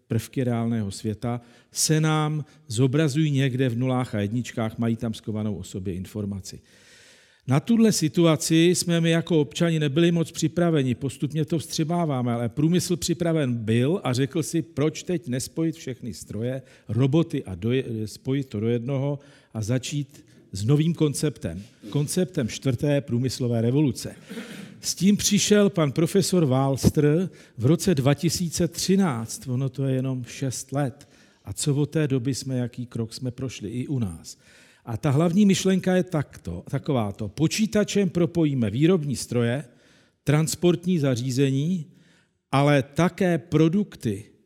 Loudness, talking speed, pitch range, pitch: -24 LUFS, 140 wpm, 120-165 Hz, 140 Hz